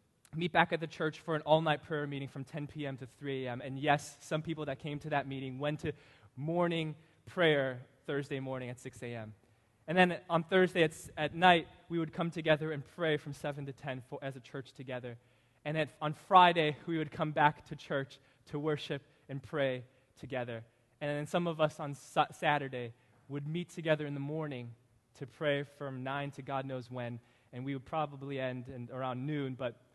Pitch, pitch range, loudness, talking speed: 145 Hz, 130-155 Hz, -34 LUFS, 205 wpm